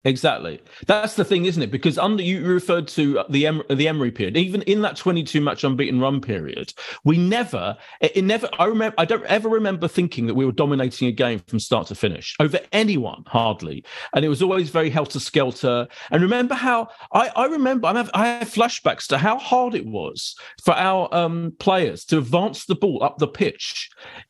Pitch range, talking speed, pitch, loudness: 140-205 Hz, 205 wpm, 170 Hz, -21 LUFS